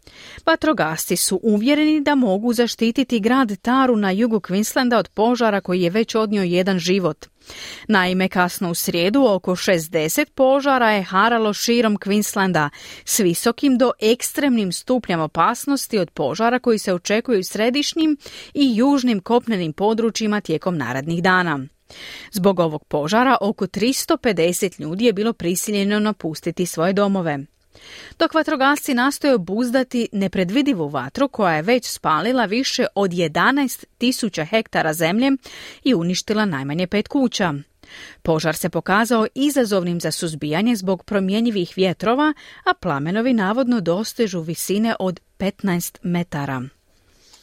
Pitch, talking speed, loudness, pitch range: 210 Hz, 125 wpm, -19 LUFS, 180-245 Hz